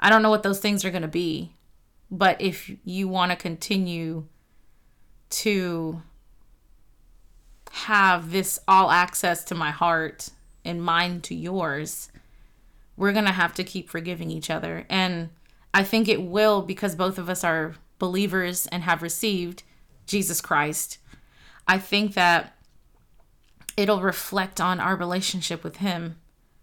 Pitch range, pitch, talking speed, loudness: 170-195 Hz, 180 Hz, 140 wpm, -24 LUFS